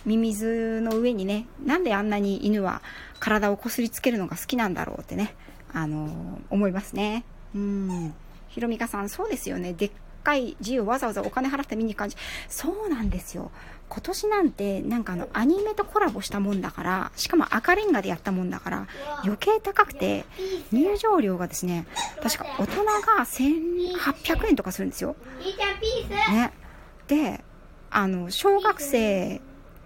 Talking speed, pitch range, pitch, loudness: 315 characters per minute, 200-330 Hz, 230 Hz, -26 LUFS